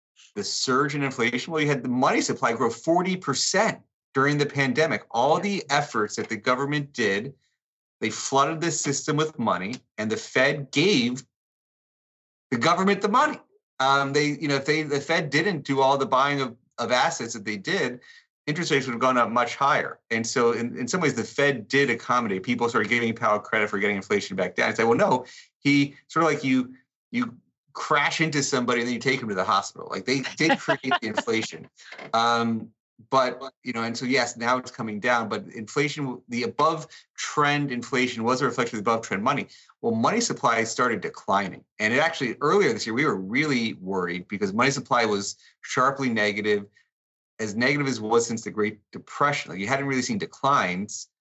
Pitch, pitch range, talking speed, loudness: 135 Hz, 115-145 Hz, 200 wpm, -24 LUFS